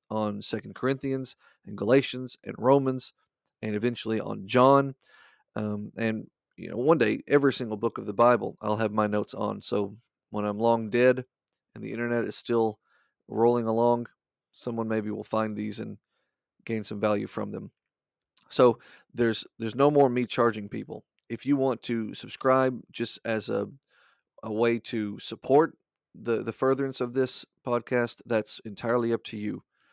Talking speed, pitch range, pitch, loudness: 165 wpm, 110-125 Hz, 115 Hz, -27 LUFS